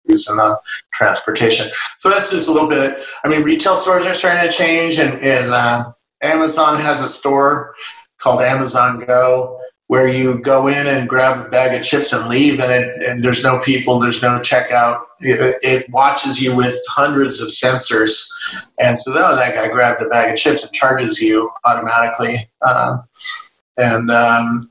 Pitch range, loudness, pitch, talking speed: 125-150 Hz, -14 LUFS, 130 Hz, 180 wpm